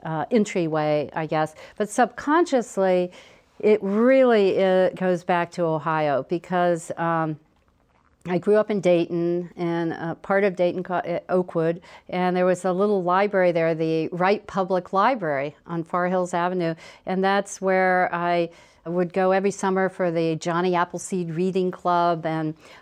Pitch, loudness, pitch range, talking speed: 180 Hz, -23 LUFS, 165-190 Hz, 145 wpm